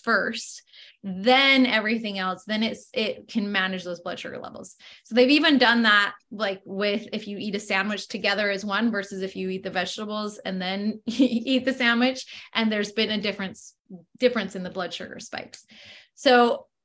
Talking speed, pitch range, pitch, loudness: 180 wpm, 195-235 Hz, 215 Hz, -24 LUFS